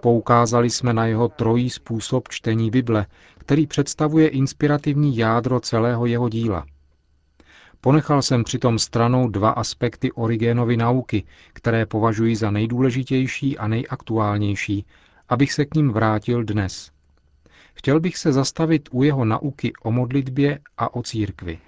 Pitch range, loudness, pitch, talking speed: 110-130 Hz, -21 LUFS, 120 Hz, 130 wpm